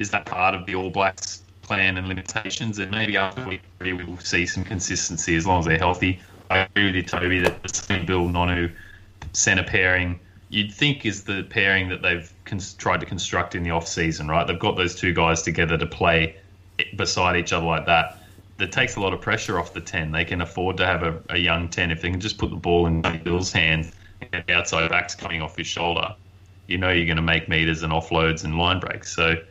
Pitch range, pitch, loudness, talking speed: 85-95 Hz, 90 Hz, -22 LUFS, 230 wpm